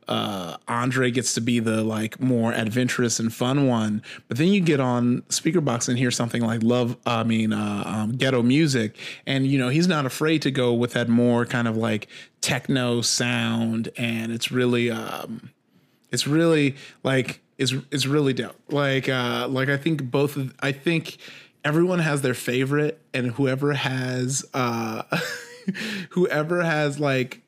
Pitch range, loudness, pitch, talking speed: 120-145 Hz, -23 LUFS, 125 Hz, 170 wpm